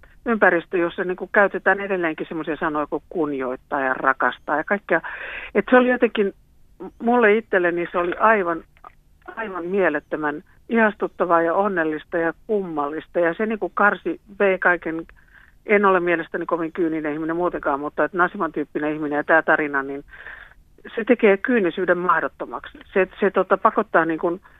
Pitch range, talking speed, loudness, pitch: 160-200 Hz, 145 wpm, -21 LUFS, 175 Hz